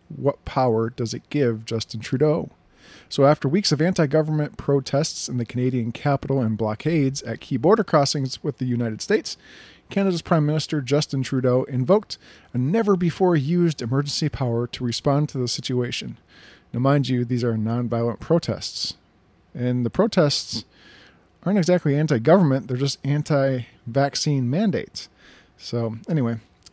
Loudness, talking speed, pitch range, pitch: -22 LUFS, 150 wpm, 120-155 Hz, 135 Hz